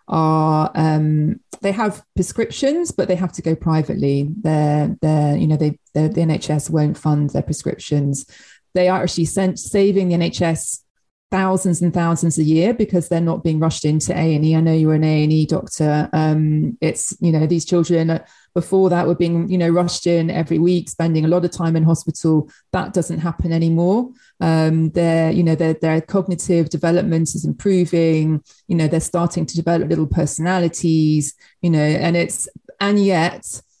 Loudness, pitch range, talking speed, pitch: -18 LUFS, 155-175 Hz, 175 wpm, 165 Hz